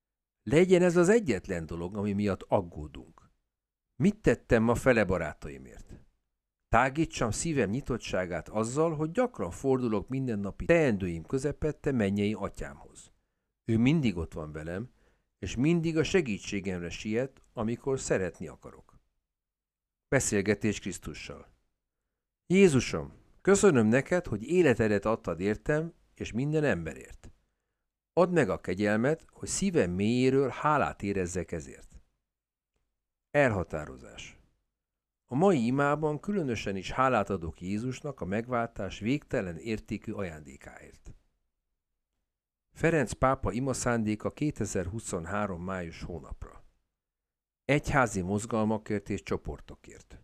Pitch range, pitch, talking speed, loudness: 95-140 Hz, 110 Hz, 105 wpm, -29 LUFS